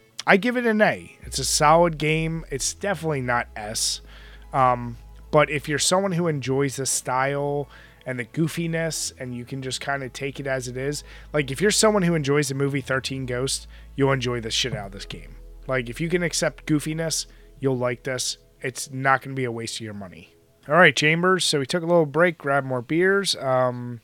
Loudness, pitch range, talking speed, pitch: -23 LUFS, 125-160 Hz, 215 wpm, 135 Hz